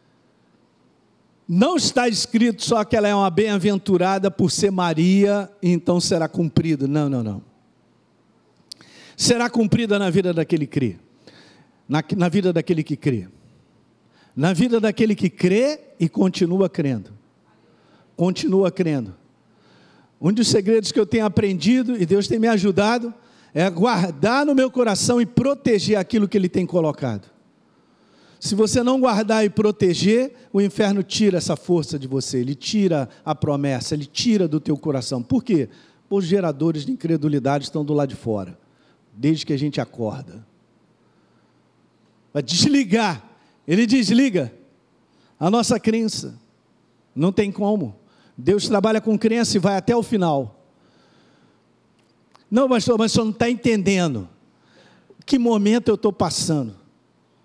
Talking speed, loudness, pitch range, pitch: 140 wpm, -20 LUFS, 155-220 Hz, 190 Hz